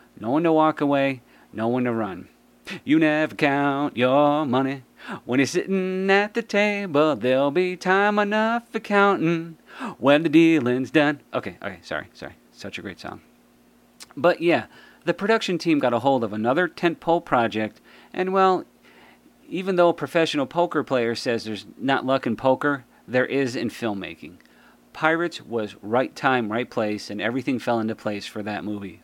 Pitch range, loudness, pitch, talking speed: 120-175 Hz, -22 LUFS, 145 Hz, 170 wpm